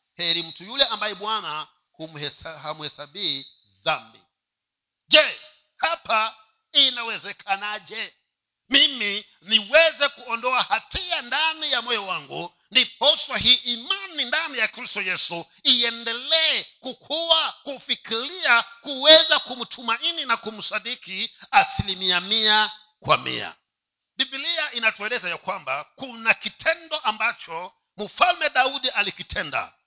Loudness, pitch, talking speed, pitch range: -20 LUFS, 235 Hz, 95 wpm, 205-285 Hz